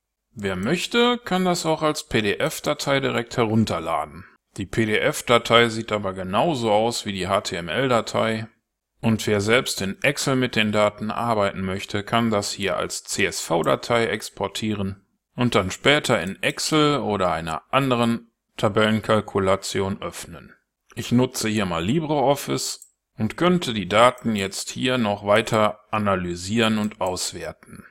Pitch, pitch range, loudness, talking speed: 110 Hz, 100-125 Hz, -22 LUFS, 130 wpm